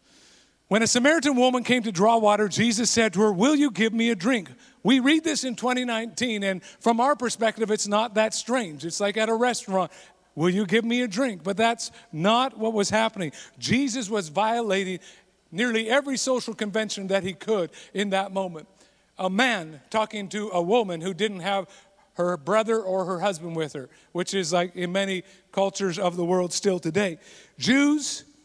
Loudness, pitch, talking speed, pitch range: -24 LUFS, 215 Hz, 190 wpm, 190-235 Hz